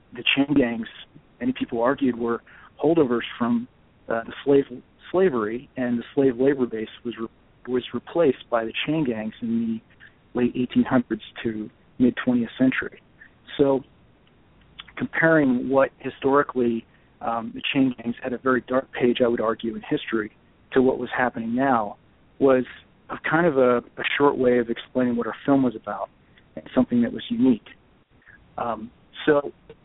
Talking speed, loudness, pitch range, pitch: 160 wpm, -23 LUFS, 115-140 Hz, 125 Hz